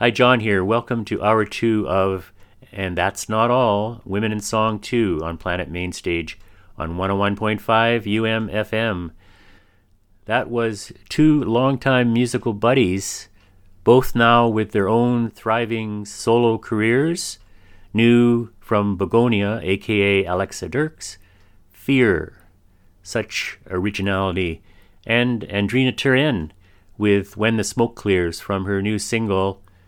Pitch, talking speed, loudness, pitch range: 105 Hz, 115 wpm, -20 LUFS, 95-115 Hz